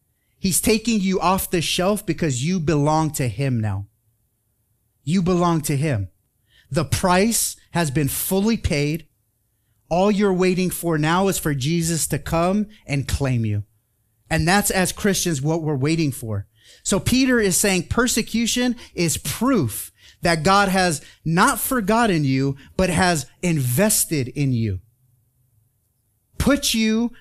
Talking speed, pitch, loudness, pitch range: 140 wpm, 160 Hz, -20 LUFS, 120-190 Hz